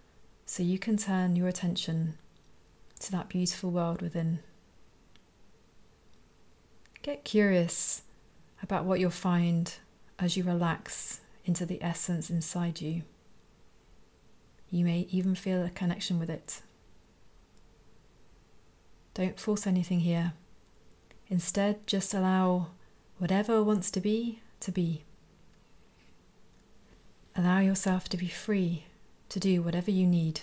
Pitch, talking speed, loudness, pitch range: 180 Hz, 110 wpm, -31 LUFS, 170-195 Hz